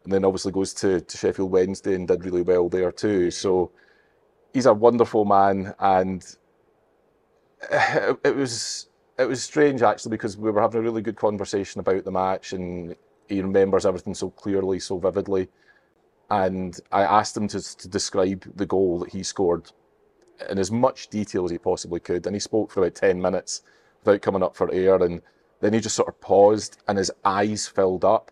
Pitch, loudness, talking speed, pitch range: 95 Hz, -23 LUFS, 190 wpm, 95-105 Hz